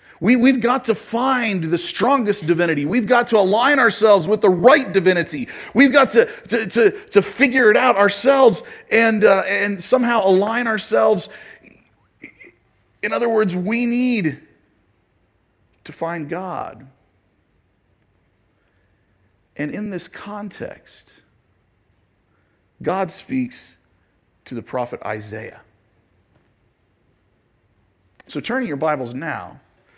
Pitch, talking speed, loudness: 175 Hz, 110 wpm, -17 LUFS